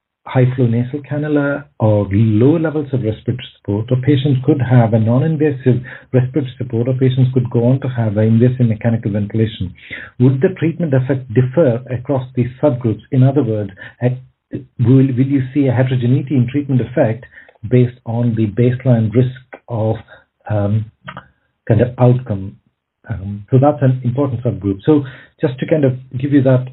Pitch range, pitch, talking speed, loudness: 115-135 Hz, 125 Hz, 165 wpm, -16 LUFS